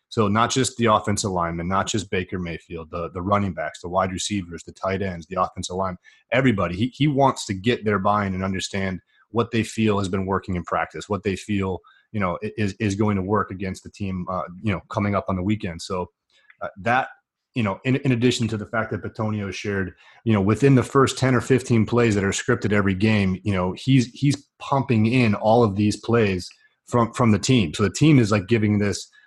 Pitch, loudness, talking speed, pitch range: 105 Hz, -22 LUFS, 230 wpm, 95-115 Hz